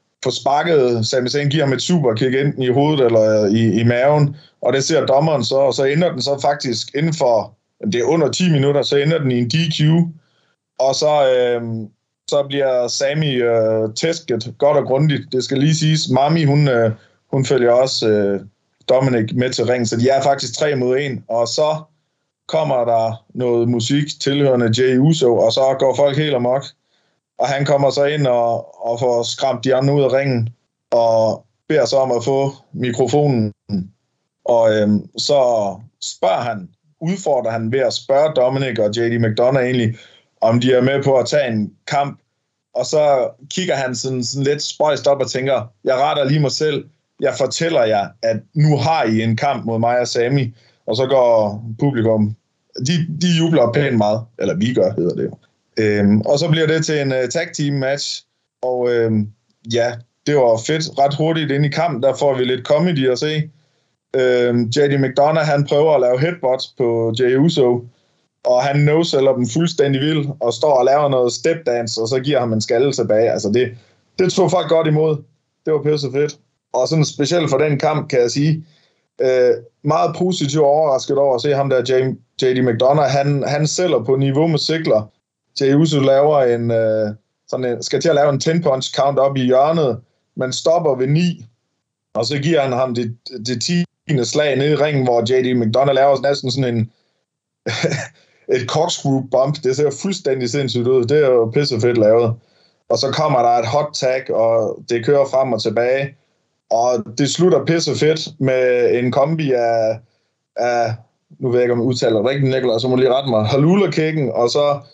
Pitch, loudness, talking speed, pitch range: 135 Hz, -17 LUFS, 195 wpm, 120-145 Hz